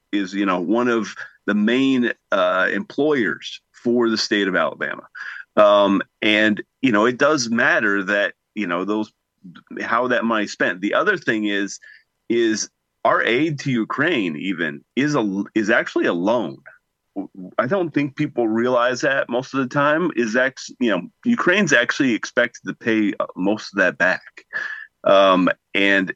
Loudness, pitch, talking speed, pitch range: -20 LUFS, 115 Hz, 160 wpm, 100-135 Hz